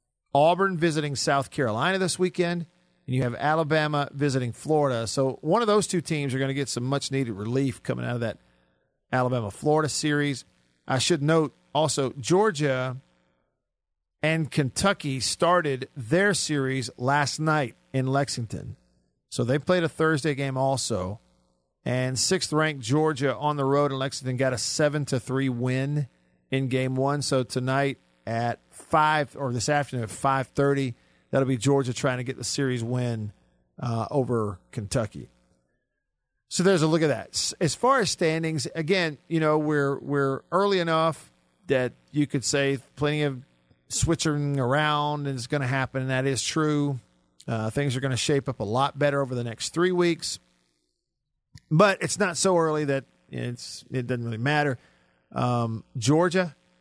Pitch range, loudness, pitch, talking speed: 125-155 Hz, -25 LUFS, 135 Hz, 160 wpm